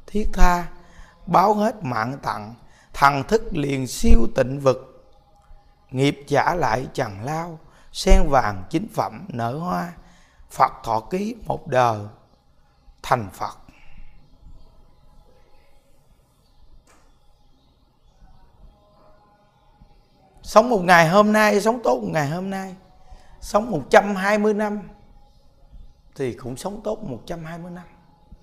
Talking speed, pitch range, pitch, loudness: 105 wpm, 115-190 Hz, 140 Hz, -21 LUFS